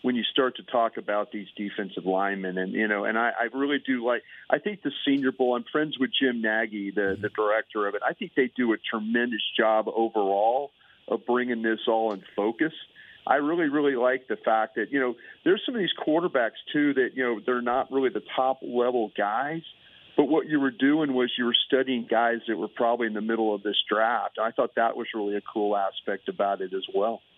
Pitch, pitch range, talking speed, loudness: 120 Hz, 105-130 Hz, 225 wpm, -26 LUFS